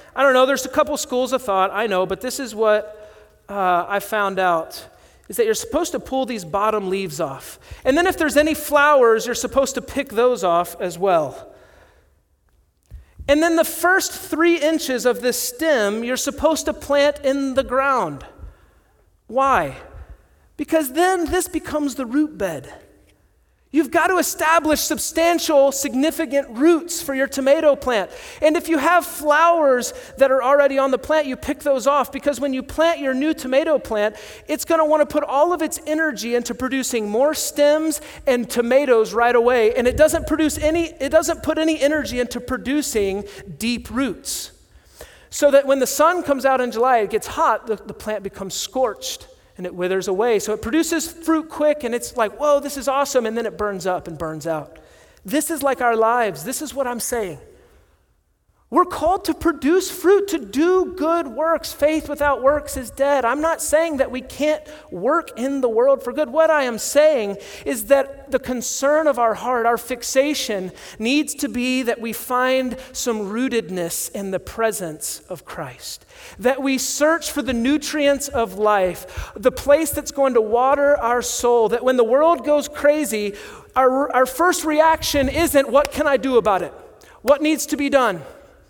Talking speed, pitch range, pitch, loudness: 185 wpm, 235-305 Hz, 275 Hz, -19 LUFS